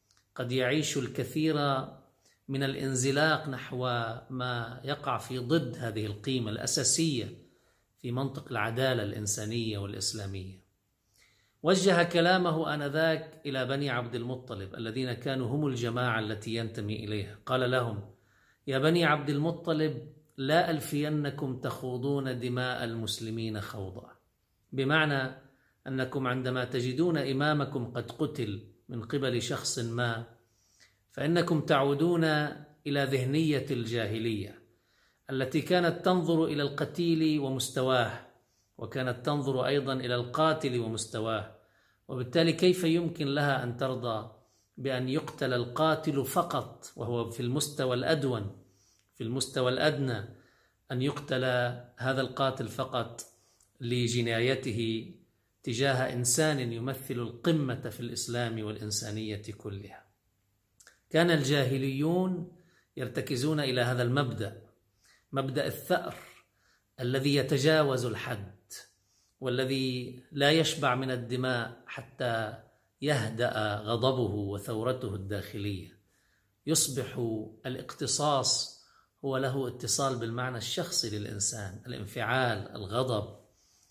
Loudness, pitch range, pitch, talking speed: -31 LUFS, 110-140 Hz, 125 Hz, 95 wpm